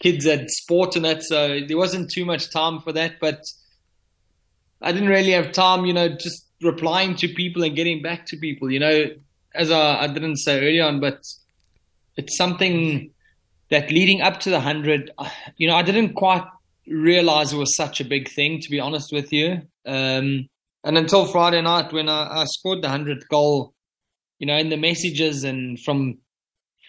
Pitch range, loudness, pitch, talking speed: 145-170 Hz, -20 LUFS, 155 Hz, 185 wpm